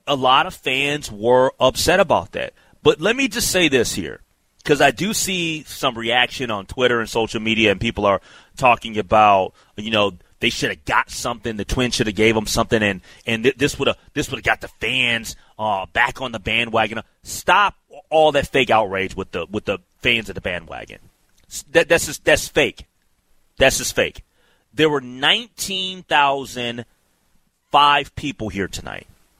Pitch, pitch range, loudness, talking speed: 120 Hz, 110-145 Hz, -19 LUFS, 175 wpm